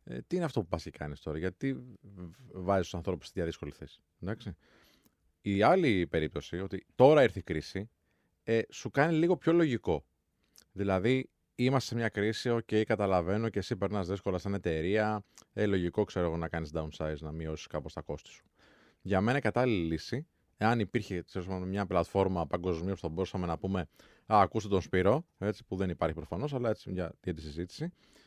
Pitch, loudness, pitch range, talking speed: 95 Hz, -32 LUFS, 85-110 Hz, 185 wpm